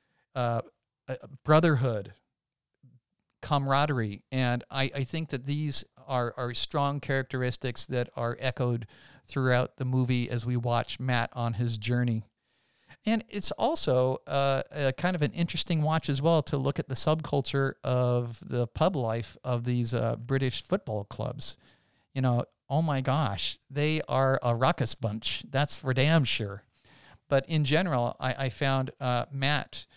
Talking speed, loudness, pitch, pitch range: 150 wpm, -29 LUFS, 130 Hz, 120-145 Hz